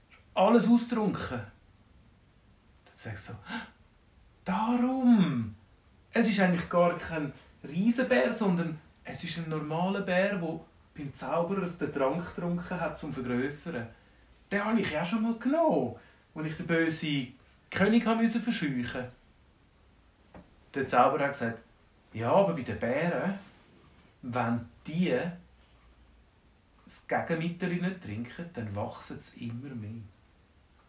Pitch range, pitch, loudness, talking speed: 110-180 Hz, 145 Hz, -30 LUFS, 120 wpm